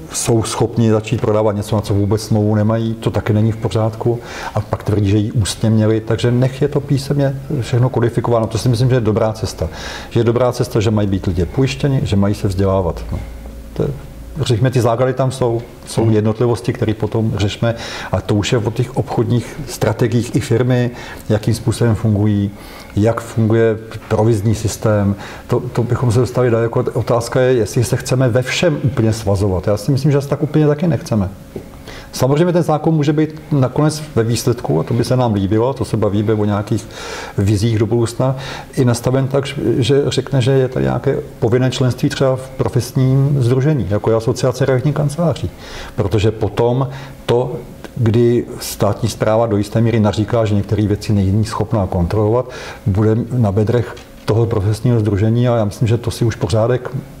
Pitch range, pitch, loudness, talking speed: 105-130 Hz, 115 Hz, -16 LUFS, 185 wpm